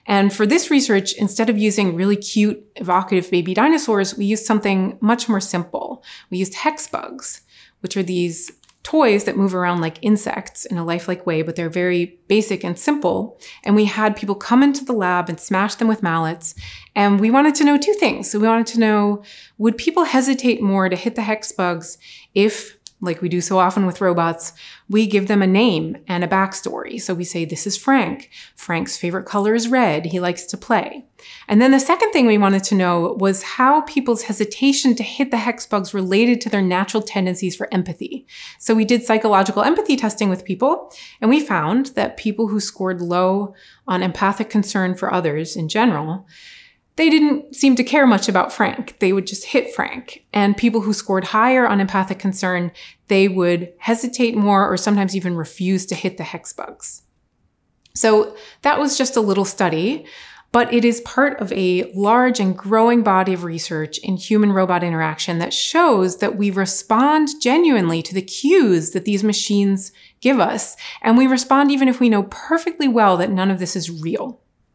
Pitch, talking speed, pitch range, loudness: 205 Hz, 195 wpm, 185-240 Hz, -18 LUFS